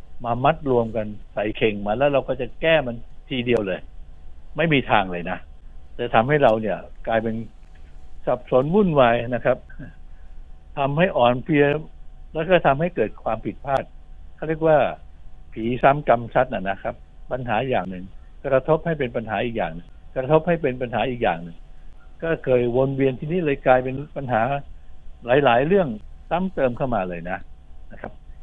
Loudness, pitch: -22 LUFS, 115 Hz